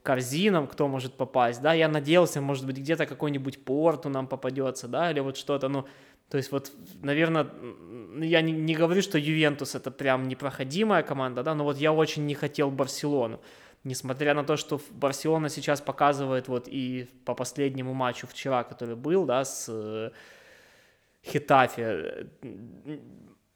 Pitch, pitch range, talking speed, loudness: 140 Hz, 130-150 Hz, 150 wpm, -28 LUFS